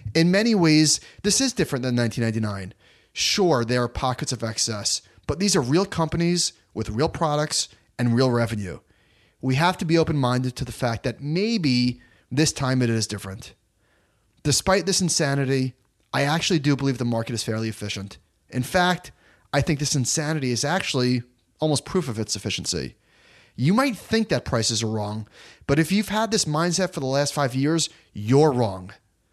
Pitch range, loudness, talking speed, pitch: 110-160 Hz, -23 LUFS, 175 wpm, 130 Hz